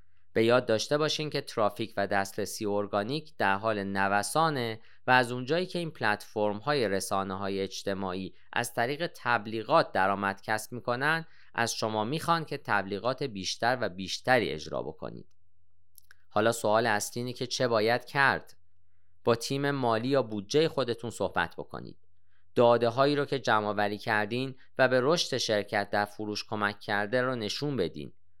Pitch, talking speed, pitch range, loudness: 110 Hz, 150 wpm, 100-130 Hz, -29 LUFS